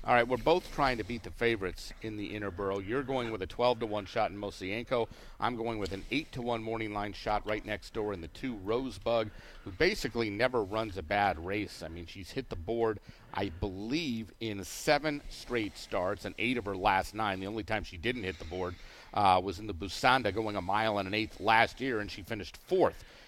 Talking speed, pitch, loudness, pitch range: 230 wpm, 105 Hz, -33 LUFS, 95-115 Hz